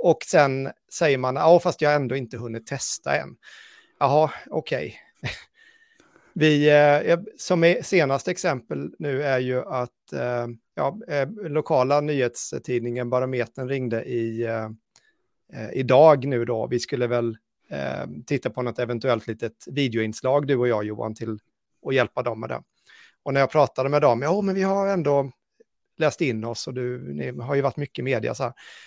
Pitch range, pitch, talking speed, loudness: 120-150 Hz, 135 Hz, 160 wpm, -23 LUFS